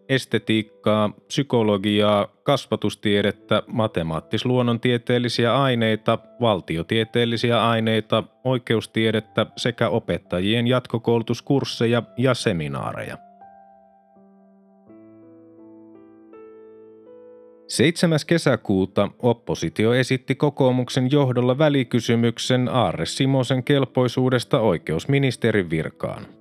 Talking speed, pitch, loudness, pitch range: 55 wpm, 115 Hz, -21 LUFS, 105-125 Hz